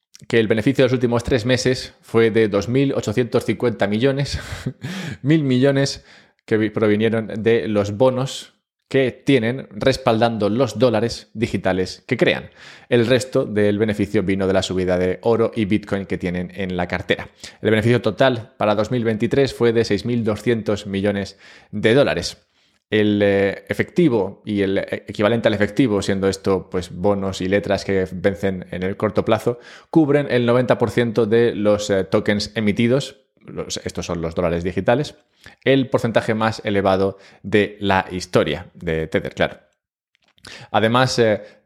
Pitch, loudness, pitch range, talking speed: 110 Hz, -19 LUFS, 100-120 Hz, 145 wpm